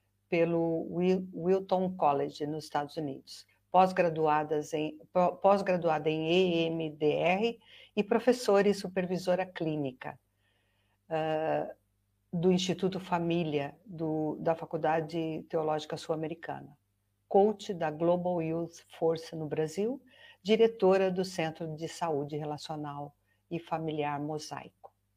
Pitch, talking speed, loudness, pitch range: 165 Hz, 100 wpm, -31 LUFS, 150-180 Hz